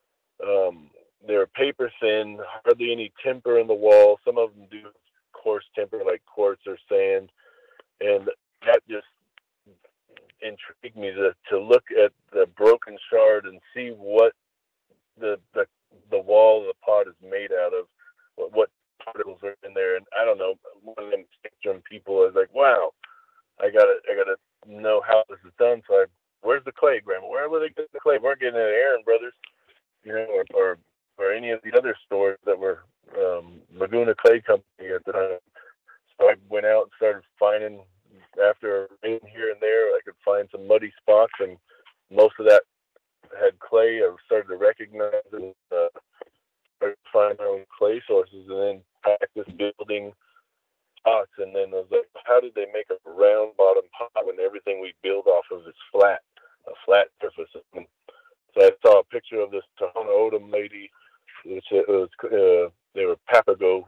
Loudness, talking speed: -22 LUFS, 180 wpm